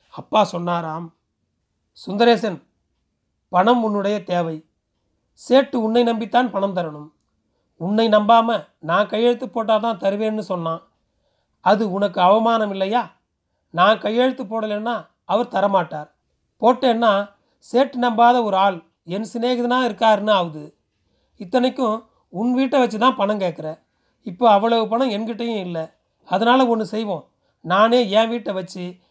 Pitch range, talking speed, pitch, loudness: 175-235 Hz, 115 wpm, 215 Hz, -19 LUFS